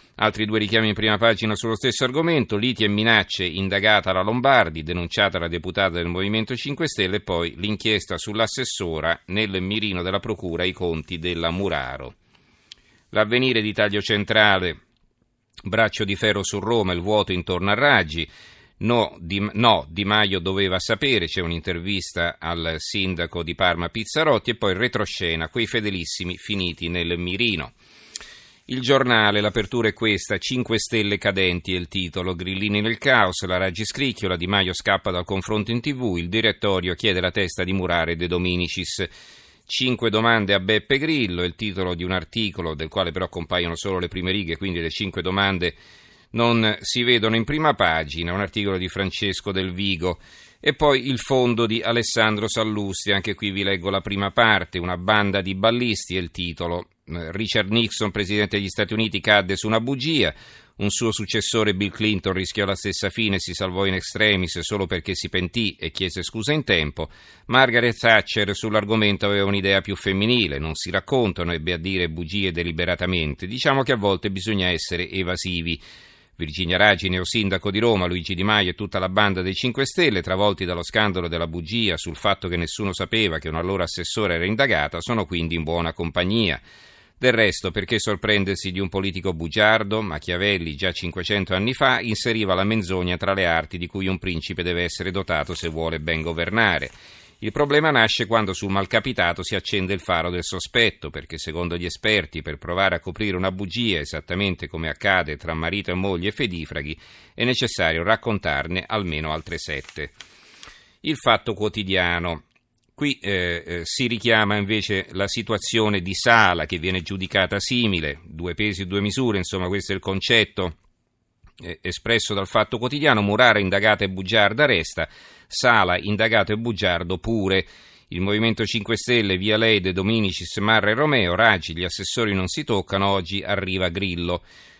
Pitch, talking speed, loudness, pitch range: 100 Hz, 170 wpm, -22 LUFS, 90-110 Hz